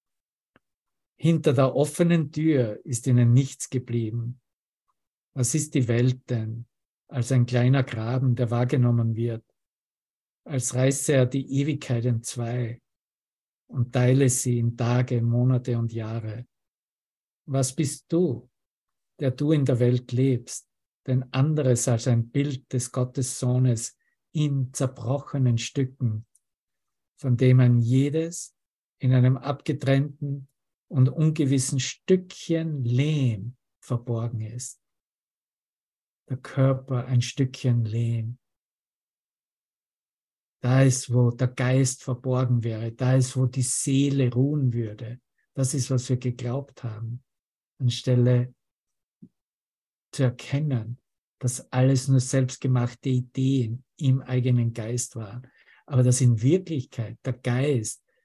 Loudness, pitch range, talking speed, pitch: -25 LUFS, 120-135 Hz, 115 wpm, 130 Hz